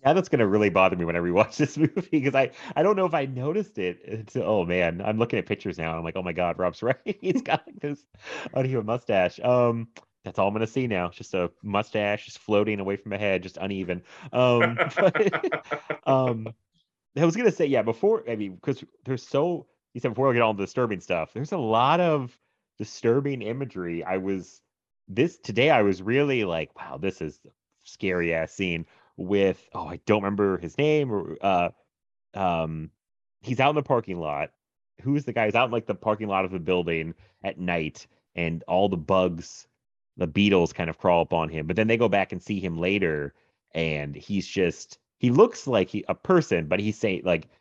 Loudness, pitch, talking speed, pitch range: -25 LUFS, 100 Hz, 215 wpm, 90-125 Hz